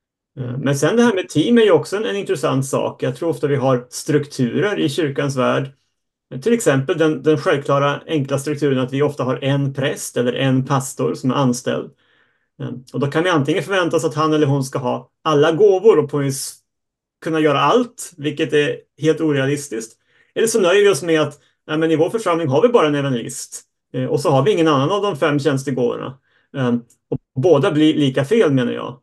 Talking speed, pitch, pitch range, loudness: 200 wpm, 145 Hz, 135-160 Hz, -18 LUFS